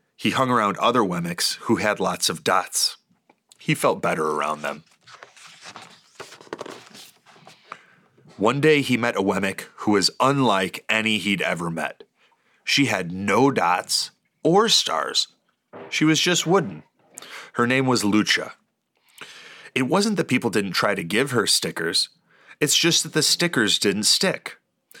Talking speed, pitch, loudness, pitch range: 140 wpm, 115 Hz, -21 LUFS, 95-155 Hz